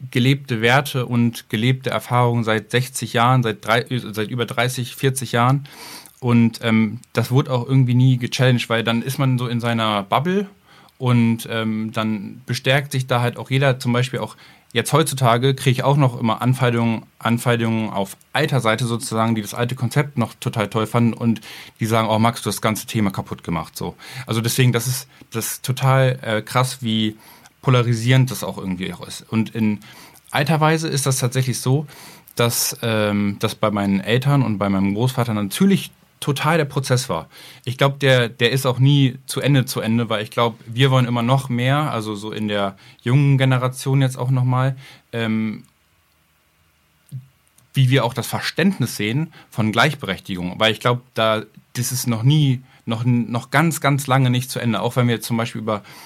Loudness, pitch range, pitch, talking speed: -20 LUFS, 110-130 Hz, 120 Hz, 185 wpm